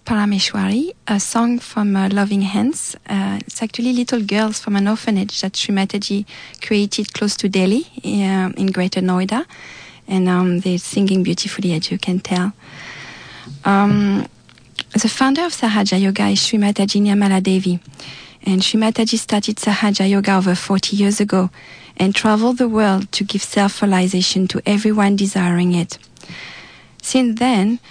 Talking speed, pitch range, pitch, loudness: 145 wpm, 190-215 Hz, 200 Hz, -17 LUFS